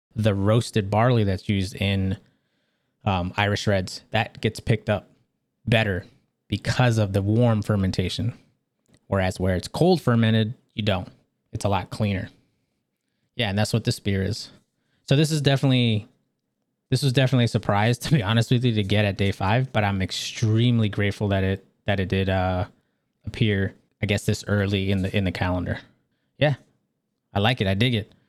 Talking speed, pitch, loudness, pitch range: 175 wpm, 105 Hz, -23 LUFS, 100-120 Hz